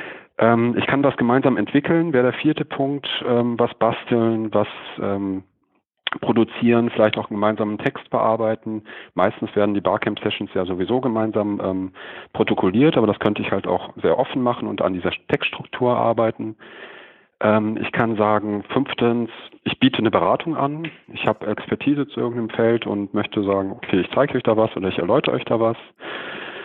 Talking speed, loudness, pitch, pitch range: 165 wpm, -21 LUFS, 115 Hz, 105-120 Hz